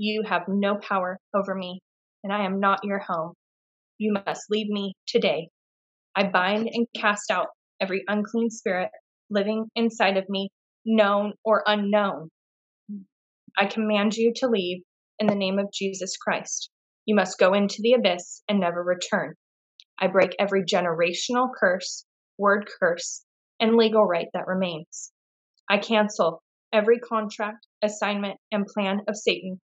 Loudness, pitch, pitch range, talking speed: -25 LUFS, 200 Hz, 190-215 Hz, 150 wpm